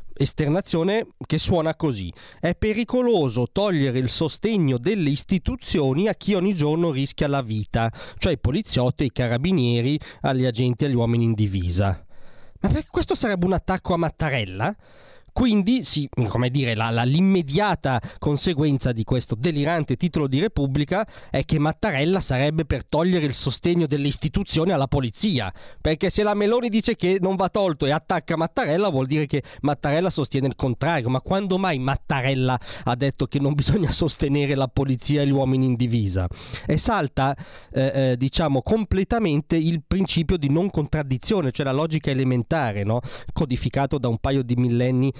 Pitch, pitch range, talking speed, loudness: 145 Hz, 130-175 Hz, 160 wpm, -23 LUFS